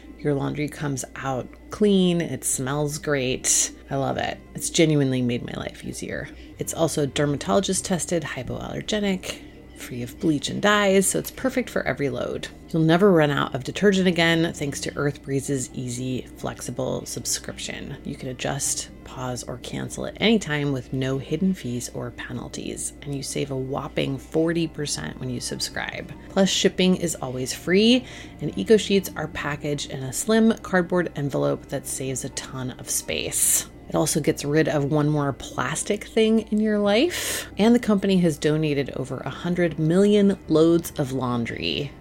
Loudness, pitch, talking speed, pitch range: -24 LUFS, 150 Hz, 165 wpm, 135-185 Hz